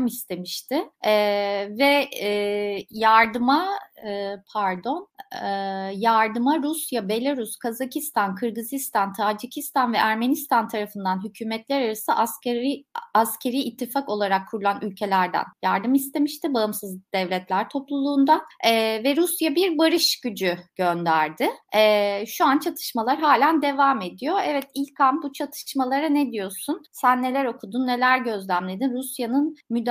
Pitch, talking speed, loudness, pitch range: 240 Hz, 115 wpm, -23 LUFS, 205-280 Hz